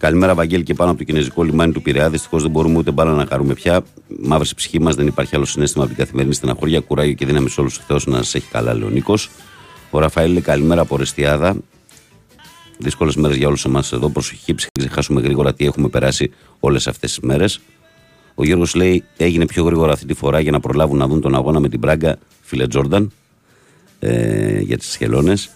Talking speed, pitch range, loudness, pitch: 205 wpm, 70-80 Hz, -17 LUFS, 75 Hz